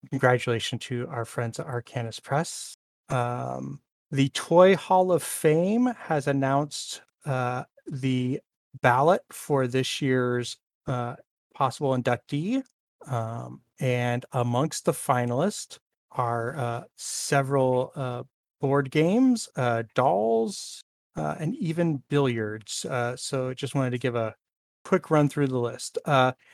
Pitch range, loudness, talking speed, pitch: 120-150 Hz, -26 LUFS, 120 wpm, 130 Hz